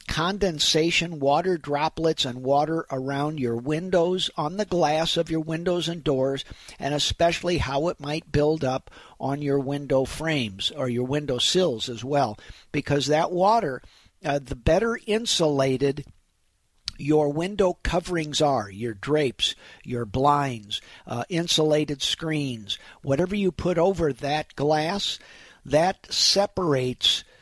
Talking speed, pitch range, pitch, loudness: 130 wpm, 135-170 Hz, 150 Hz, -24 LUFS